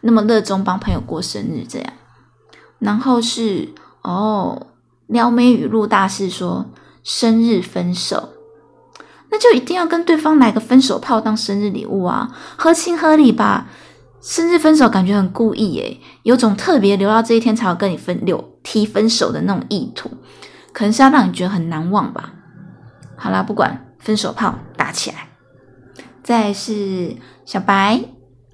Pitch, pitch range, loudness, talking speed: 220 Hz, 195-245 Hz, -16 LUFS, 235 characters per minute